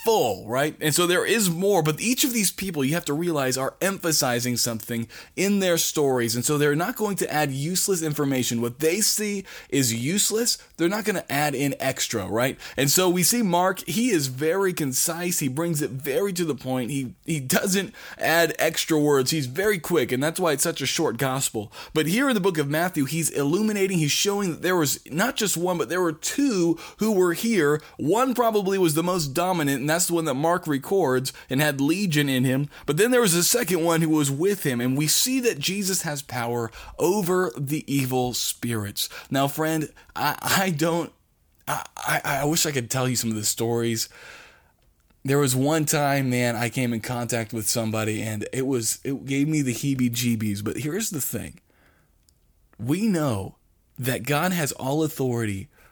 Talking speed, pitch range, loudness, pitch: 200 wpm, 130-180 Hz, -23 LUFS, 150 Hz